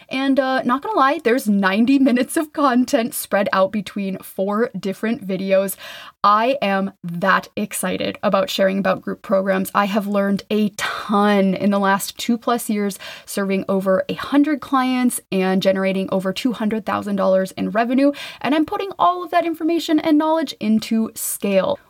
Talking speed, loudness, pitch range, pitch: 160 wpm, -19 LUFS, 195-265 Hz, 210 Hz